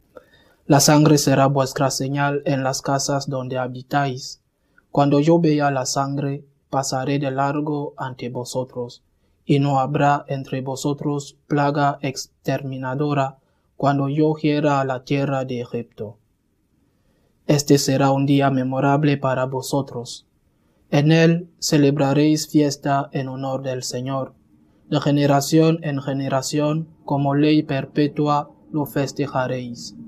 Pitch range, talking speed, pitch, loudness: 130-145 Hz, 120 wpm, 140 Hz, -20 LUFS